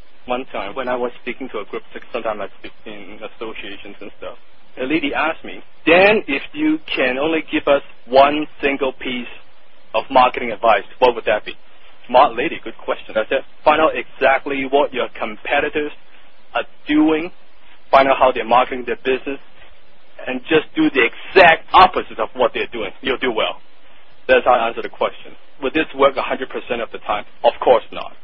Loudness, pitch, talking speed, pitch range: -17 LUFS, 140 Hz, 185 wpm, 130-160 Hz